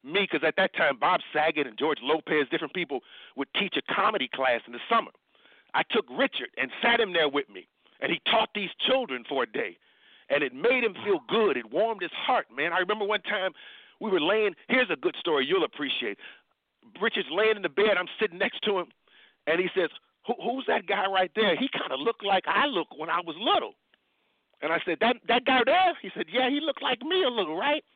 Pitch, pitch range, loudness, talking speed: 215 Hz, 185-255 Hz, -27 LUFS, 230 wpm